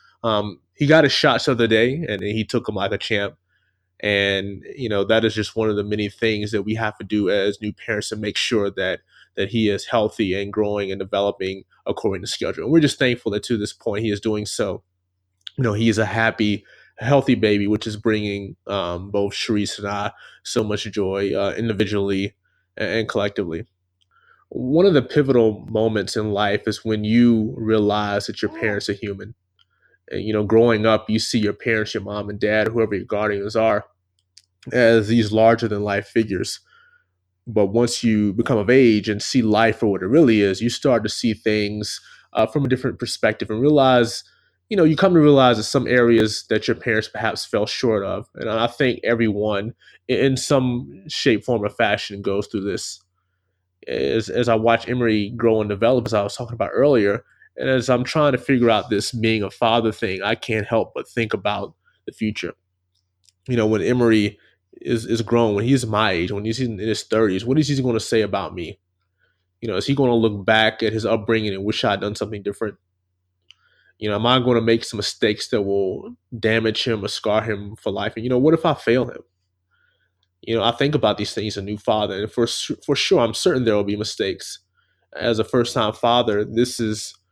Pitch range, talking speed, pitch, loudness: 100-115 Hz, 210 wpm, 110 Hz, -20 LUFS